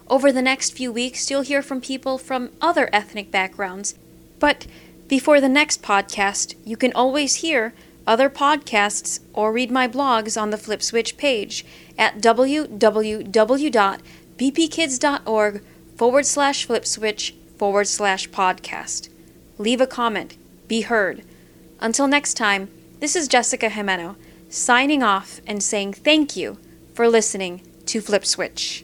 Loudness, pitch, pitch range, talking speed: -20 LUFS, 225 Hz, 200-270 Hz, 135 wpm